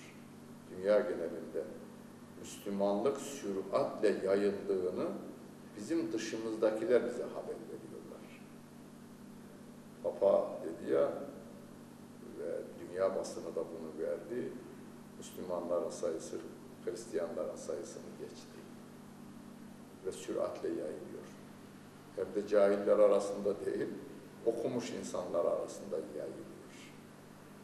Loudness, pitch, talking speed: -36 LUFS, 225 Hz, 80 wpm